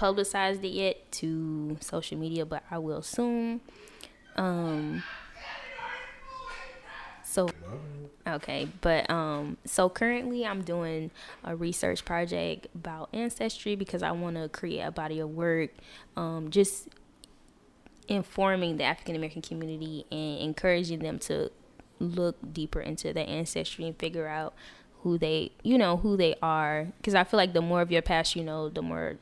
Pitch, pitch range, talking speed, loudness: 170 Hz, 160-195 Hz, 150 wpm, -31 LUFS